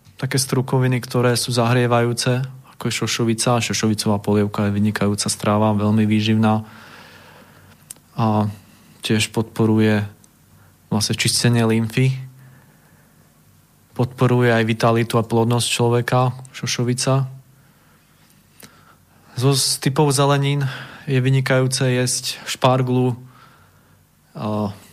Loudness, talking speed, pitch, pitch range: -19 LUFS, 90 wpm, 120 Hz, 110-130 Hz